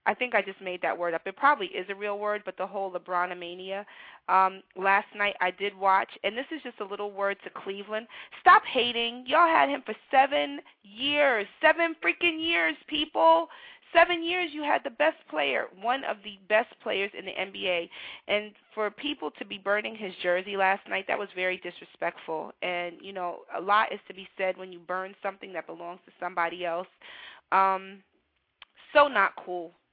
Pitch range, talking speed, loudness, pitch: 185-270 Hz, 195 wpm, -27 LUFS, 205 Hz